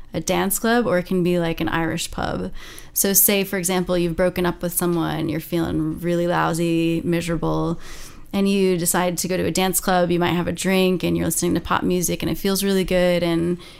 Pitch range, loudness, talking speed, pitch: 170-185 Hz, -20 LUFS, 220 wpm, 175 Hz